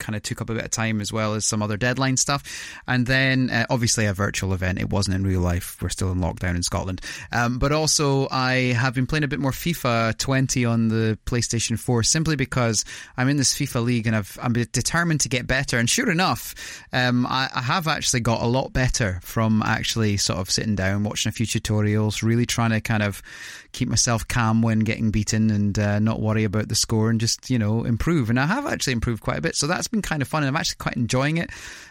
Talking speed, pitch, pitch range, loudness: 240 wpm, 115 Hz, 110-130 Hz, -22 LUFS